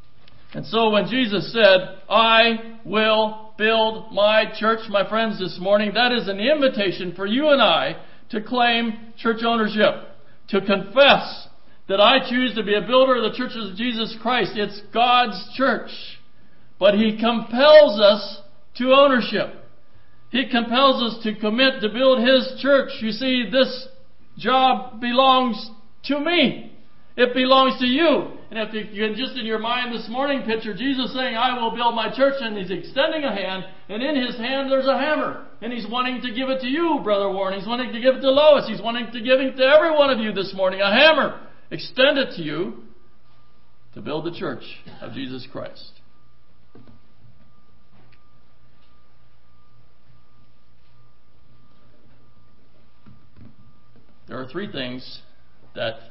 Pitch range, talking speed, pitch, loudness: 200-260 Hz, 155 wpm, 225 Hz, -19 LUFS